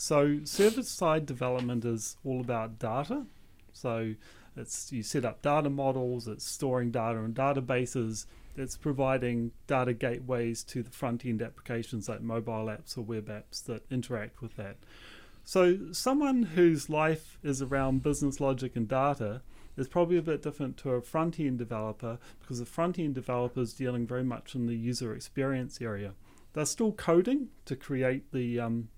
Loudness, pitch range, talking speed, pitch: -32 LUFS, 115-145 Hz, 165 wpm, 125 Hz